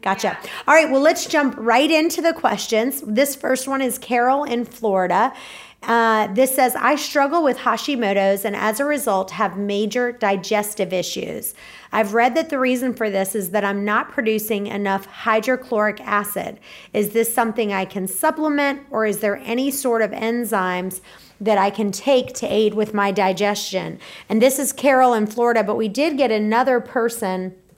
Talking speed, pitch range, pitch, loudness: 175 wpm, 205-260 Hz, 225 Hz, -19 LUFS